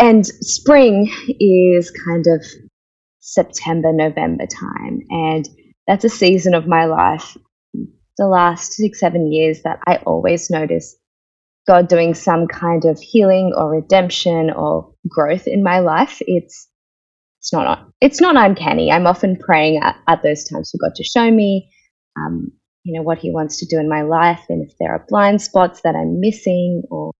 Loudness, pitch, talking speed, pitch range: -15 LUFS, 170 Hz, 170 wpm, 160-190 Hz